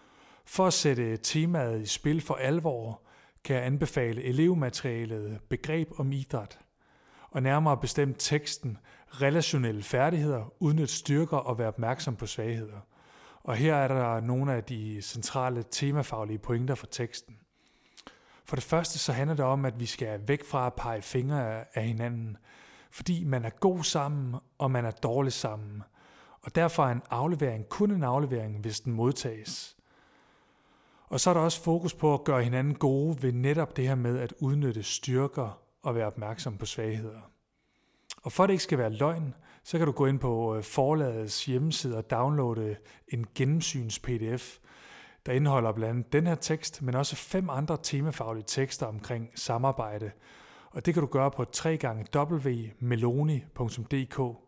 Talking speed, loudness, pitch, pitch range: 160 wpm, -30 LUFS, 130 Hz, 115-145 Hz